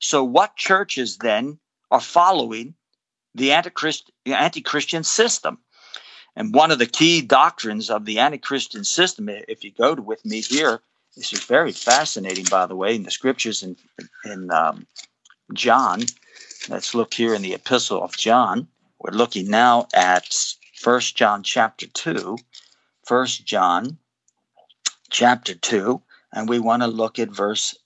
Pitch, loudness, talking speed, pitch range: 120 Hz, -20 LUFS, 150 wpm, 110-155 Hz